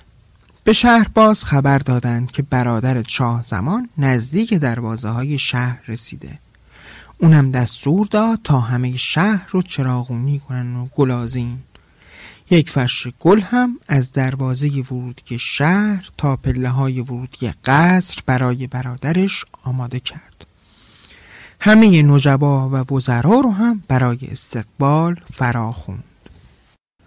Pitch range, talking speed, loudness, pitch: 125-165 Hz, 115 wpm, -17 LUFS, 130 Hz